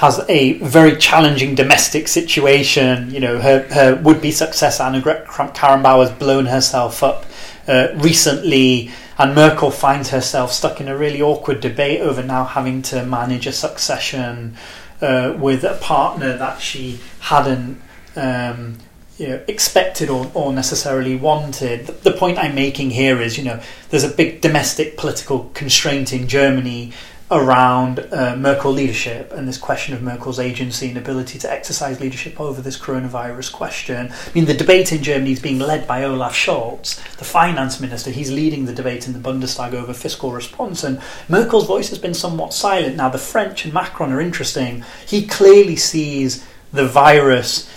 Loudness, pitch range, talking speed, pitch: -16 LUFS, 130-150 Hz, 170 wpm, 135 Hz